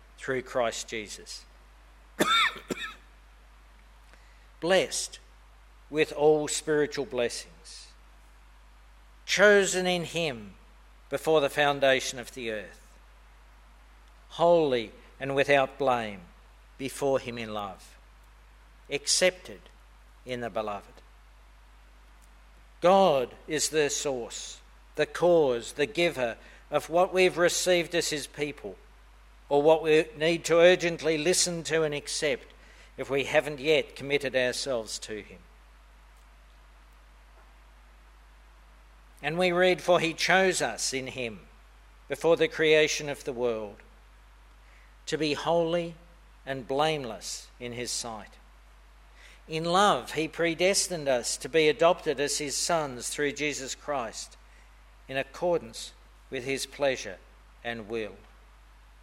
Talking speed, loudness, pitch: 110 wpm, -27 LUFS, 135 Hz